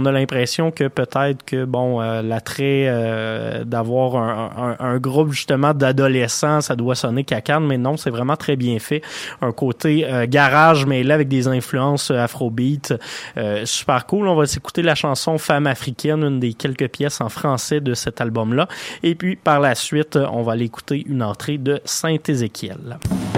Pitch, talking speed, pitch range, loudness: 135 Hz, 180 wpm, 120-150 Hz, -19 LUFS